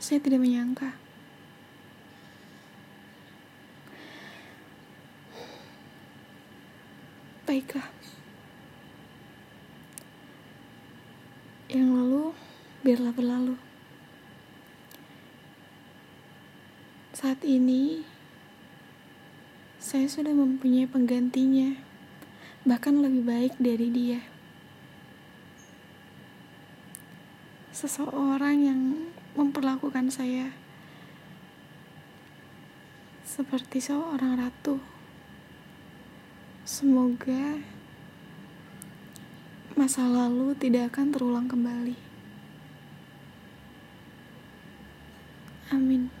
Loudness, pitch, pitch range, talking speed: -27 LUFS, 260 Hz, 250-275 Hz, 45 wpm